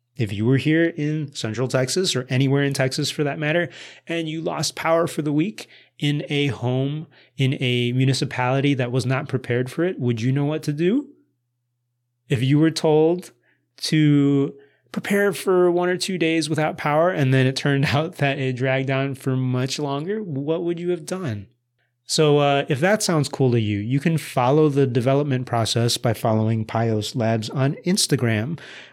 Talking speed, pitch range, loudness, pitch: 185 wpm, 130-160 Hz, -21 LUFS, 140 Hz